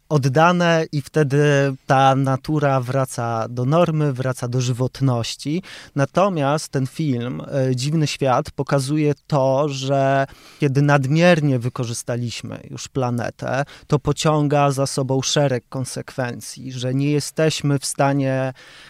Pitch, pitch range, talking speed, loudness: 140 Hz, 130-145 Hz, 110 wpm, -20 LUFS